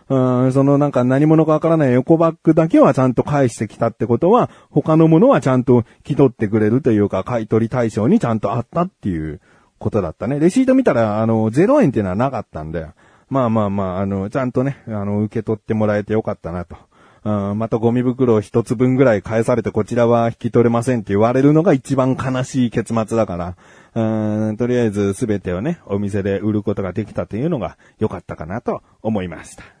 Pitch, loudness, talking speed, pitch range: 115 Hz, -17 LUFS, 445 characters per minute, 105-130 Hz